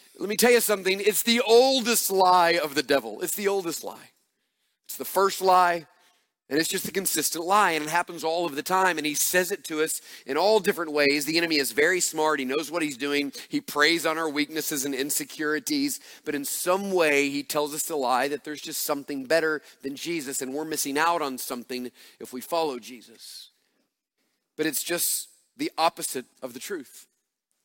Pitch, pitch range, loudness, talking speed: 160 Hz, 145-185 Hz, -25 LUFS, 205 wpm